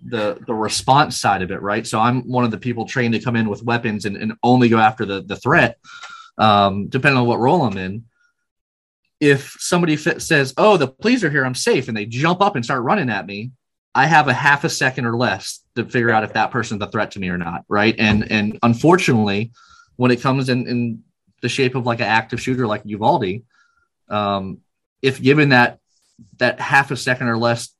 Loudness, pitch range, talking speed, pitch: -18 LUFS, 110-135 Hz, 220 wpm, 120 Hz